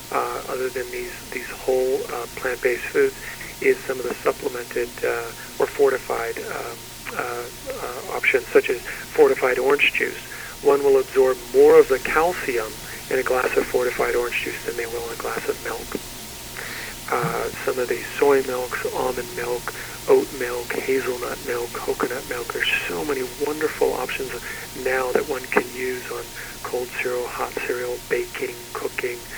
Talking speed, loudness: 160 wpm, -23 LUFS